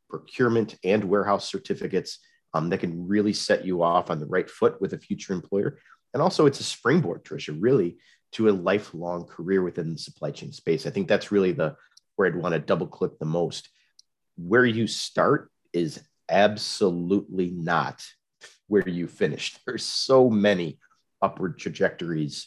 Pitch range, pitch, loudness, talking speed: 85-105 Hz, 95 Hz, -25 LUFS, 165 wpm